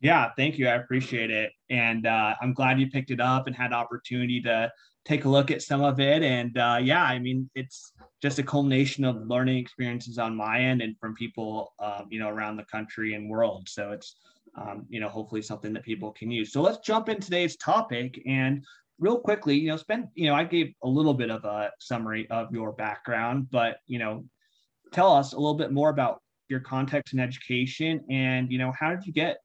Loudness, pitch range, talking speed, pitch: -27 LUFS, 115-140 Hz, 220 wpm, 125 Hz